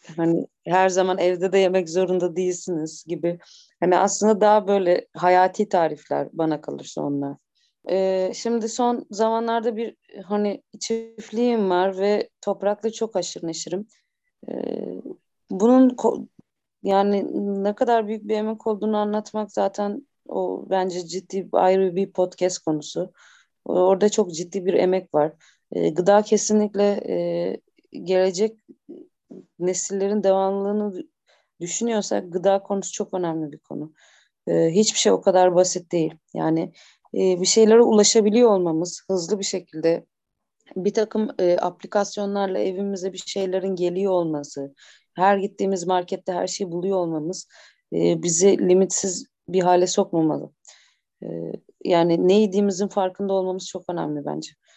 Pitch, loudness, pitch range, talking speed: 190 Hz, -22 LUFS, 180-210 Hz, 130 wpm